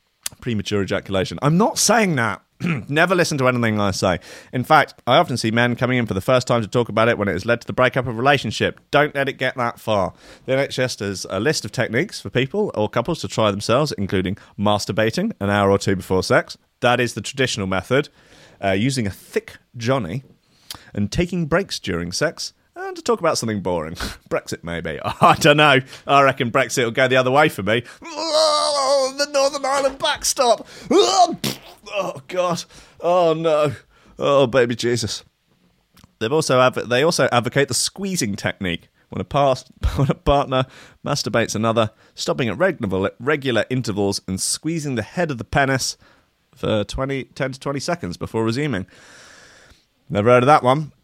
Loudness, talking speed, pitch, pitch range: -20 LUFS, 185 wpm, 125 Hz, 105-150 Hz